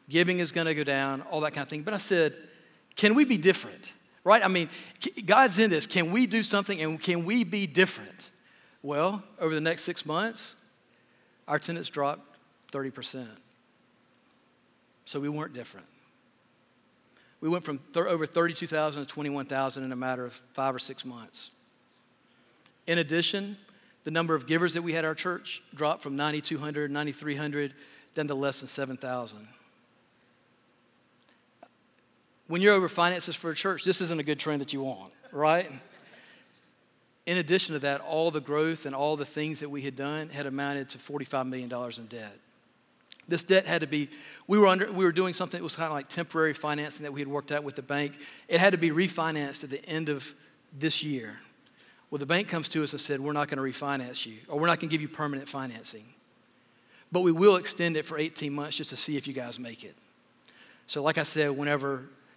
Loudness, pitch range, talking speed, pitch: -29 LUFS, 140-170 Hz, 195 wpm, 150 Hz